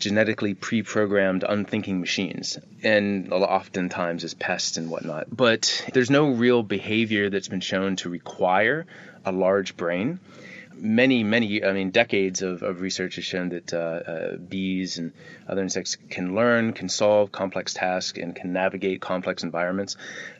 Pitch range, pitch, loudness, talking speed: 90-105 Hz, 95 Hz, -24 LUFS, 155 wpm